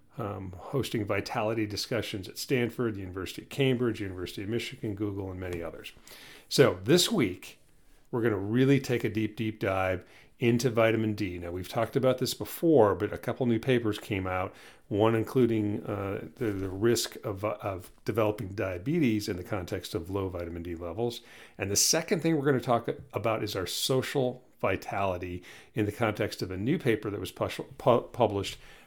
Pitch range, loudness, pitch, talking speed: 100-120 Hz, -29 LUFS, 110 Hz, 185 wpm